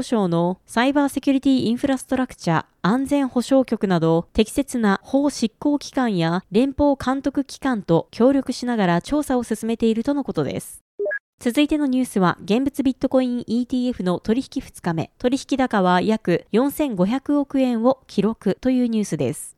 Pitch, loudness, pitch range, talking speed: 245 Hz, -21 LUFS, 205-270 Hz, 335 characters per minute